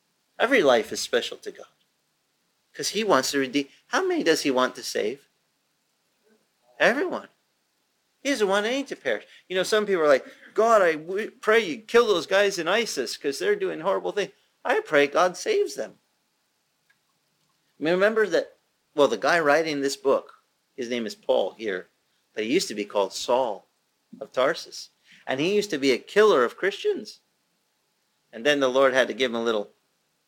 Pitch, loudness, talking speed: 205 Hz, -24 LUFS, 185 wpm